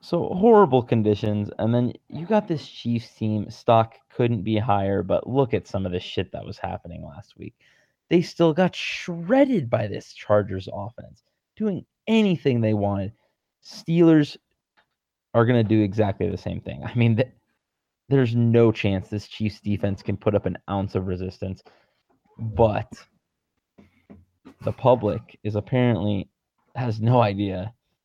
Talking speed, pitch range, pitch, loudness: 150 wpm, 100-130 Hz, 110 Hz, -23 LUFS